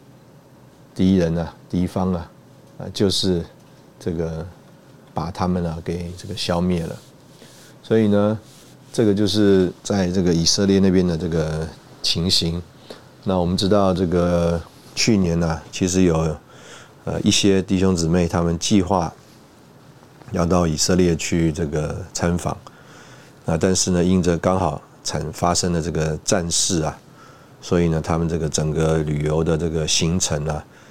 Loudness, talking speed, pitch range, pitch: -20 LUFS, 215 characters per minute, 85-100 Hz, 90 Hz